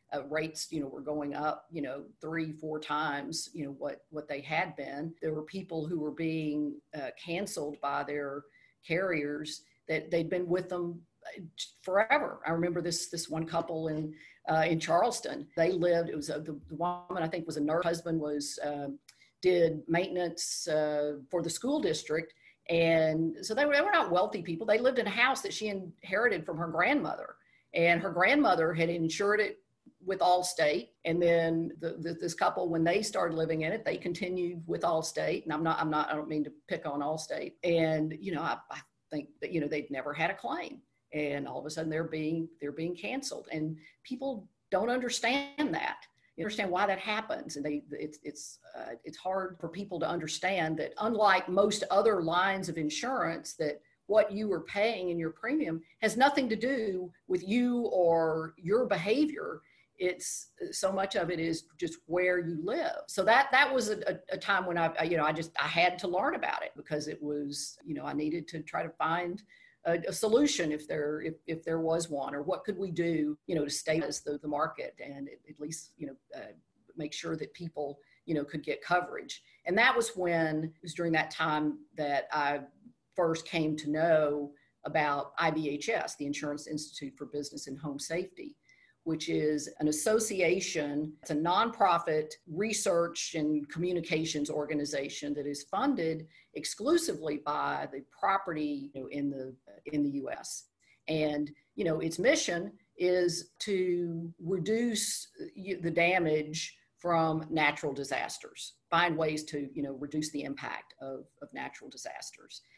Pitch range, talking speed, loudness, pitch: 150-180 Hz, 185 wpm, -32 LUFS, 165 Hz